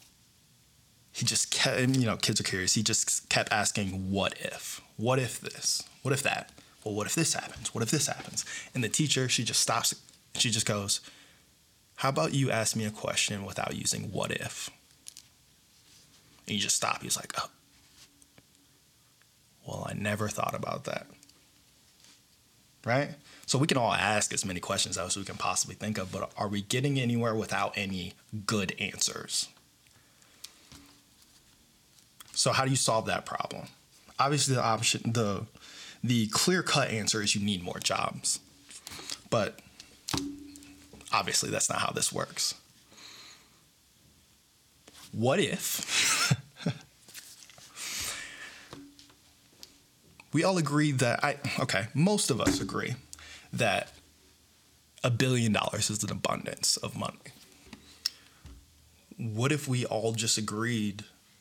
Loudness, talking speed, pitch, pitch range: -29 LUFS, 135 wpm, 115 Hz, 105-135 Hz